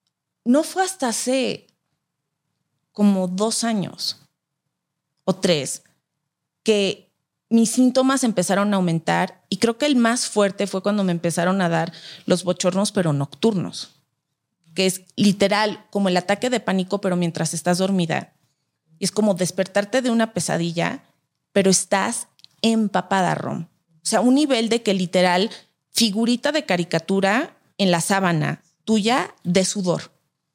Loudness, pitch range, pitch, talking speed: -21 LUFS, 170-220 Hz, 190 Hz, 140 wpm